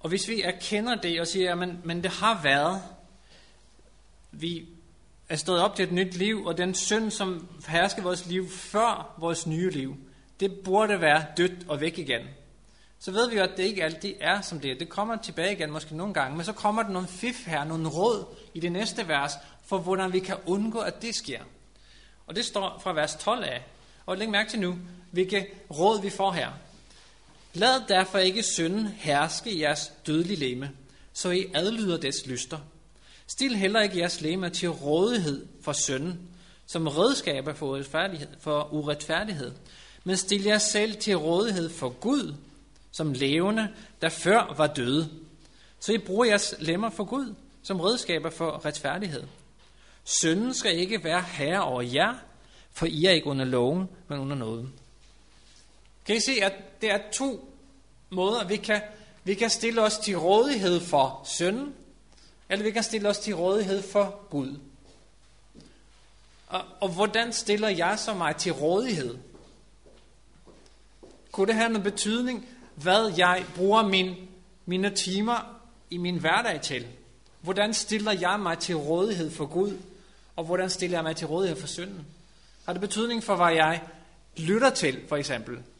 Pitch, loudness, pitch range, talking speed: 185 Hz, -27 LUFS, 160-210 Hz, 170 wpm